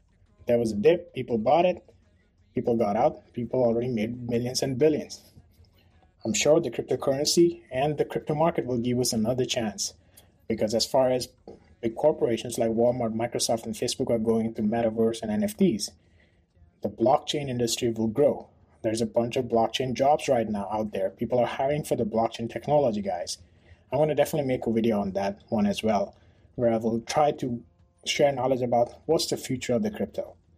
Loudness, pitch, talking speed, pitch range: -26 LUFS, 115 Hz, 185 wpm, 110-130 Hz